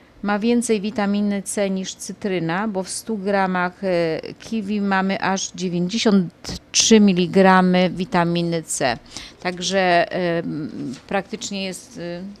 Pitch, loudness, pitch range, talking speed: 190 Hz, -20 LUFS, 180-205 Hz, 105 wpm